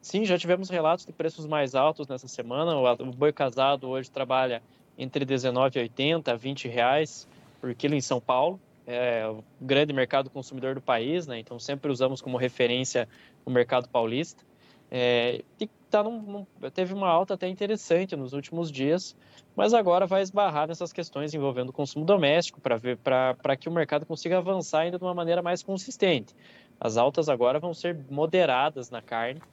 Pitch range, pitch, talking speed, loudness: 130-175 Hz, 145 Hz, 175 wpm, -27 LUFS